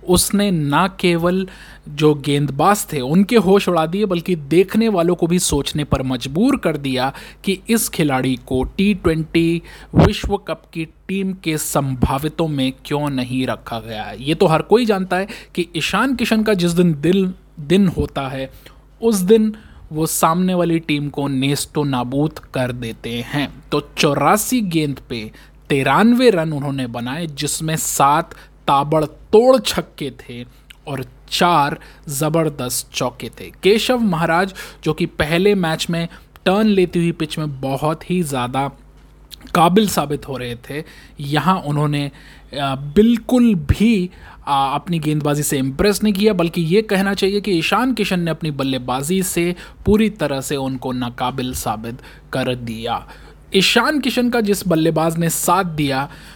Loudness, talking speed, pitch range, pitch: -18 LUFS, 150 wpm, 140-190 Hz, 160 Hz